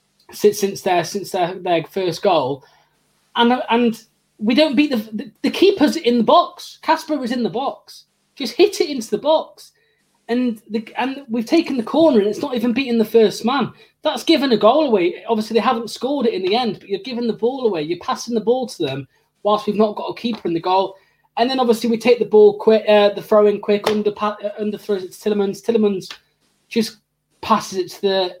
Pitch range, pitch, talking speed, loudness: 205-255 Hz, 225 Hz, 220 wpm, -18 LUFS